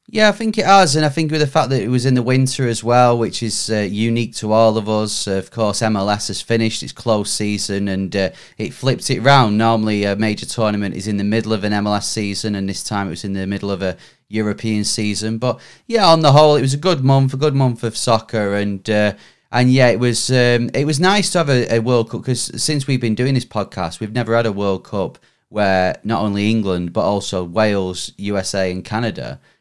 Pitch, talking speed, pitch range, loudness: 110 Hz, 240 wpm, 105-125 Hz, -17 LUFS